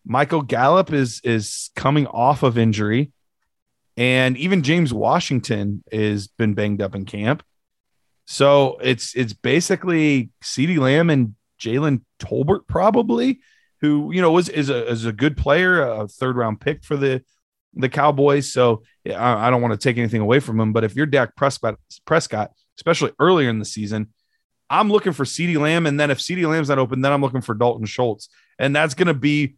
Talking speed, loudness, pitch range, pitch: 185 wpm, -19 LUFS, 115-150 Hz, 135 Hz